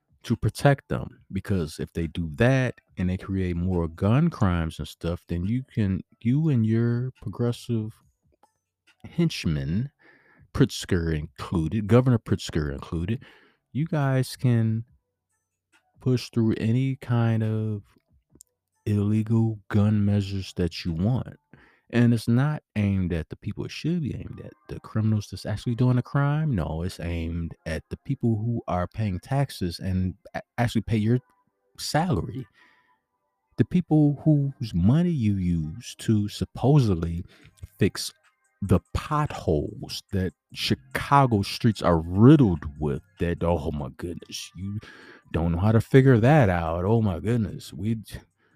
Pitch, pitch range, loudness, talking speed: 105 Hz, 90-120 Hz, -25 LUFS, 135 wpm